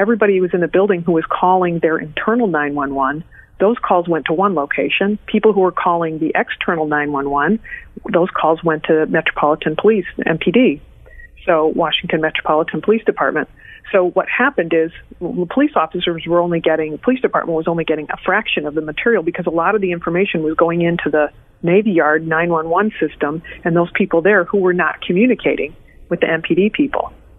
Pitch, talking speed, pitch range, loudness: 175 Hz, 205 wpm, 160-200 Hz, -16 LUFS